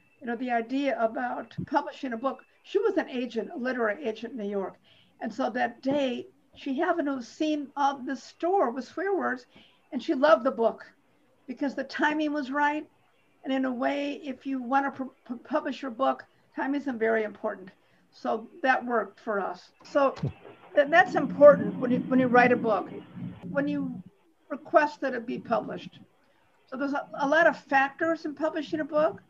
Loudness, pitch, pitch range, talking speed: -27 LUFS, 275 Hz, 245-300 Hz, 185 wpm